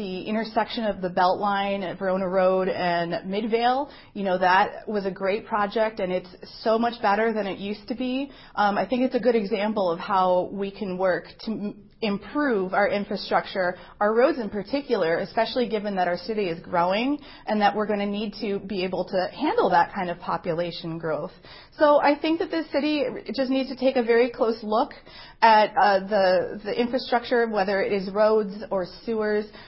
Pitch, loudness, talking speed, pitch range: 210 Hz, -24 LUFS, 190 wpm, 185-235 Hz